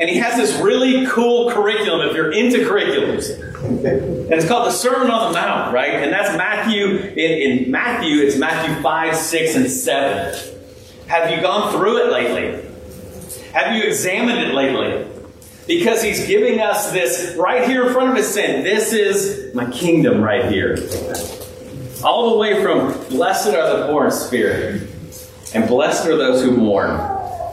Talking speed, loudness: 170 wpm, -17 LUFS